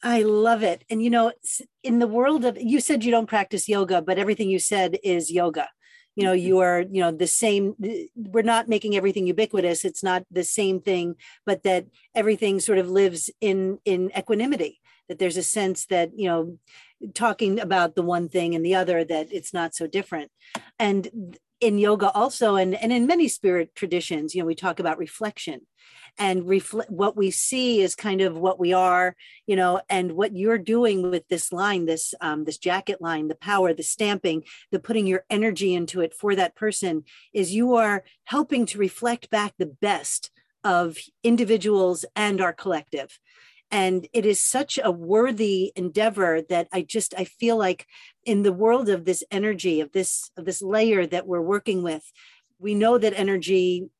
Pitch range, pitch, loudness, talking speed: 180-220 Hz, 195 Hz, -23 LUFS, 190 wpm